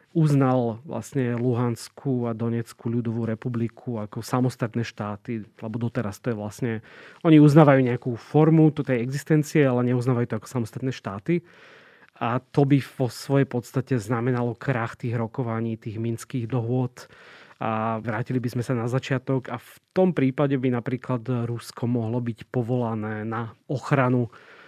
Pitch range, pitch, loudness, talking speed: 115-135 Hz, 125 Hz, -25 LUFS, 145 wpm